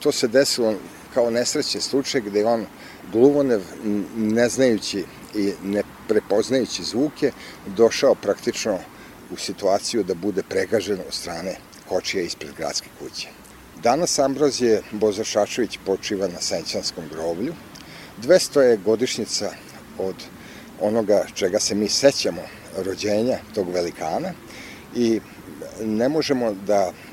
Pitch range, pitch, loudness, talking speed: 100-135 Hz, 110 Hz, -22 LUFS, 115 wpm